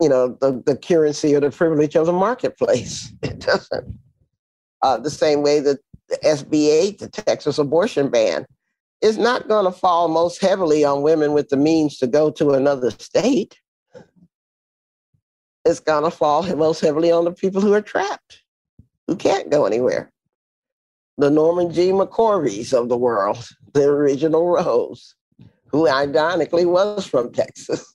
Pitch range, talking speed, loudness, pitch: 145-180 Hz, 150 wpm, -19 LUFS, 155 Hz